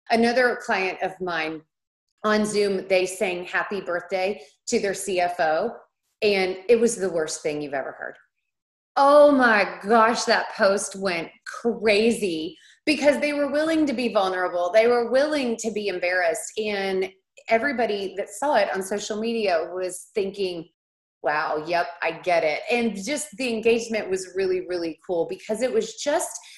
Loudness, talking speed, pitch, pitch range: -23 LUFS, 155 wpm, 200 Hz, 180-235 Hz